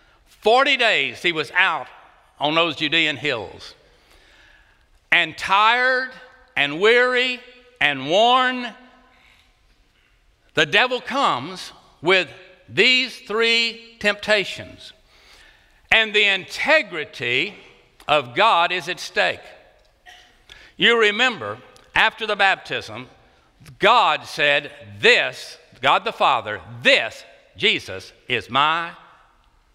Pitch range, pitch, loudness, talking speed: 170-250 Hz, 220 Hz, -18 LUFS, 90 wpm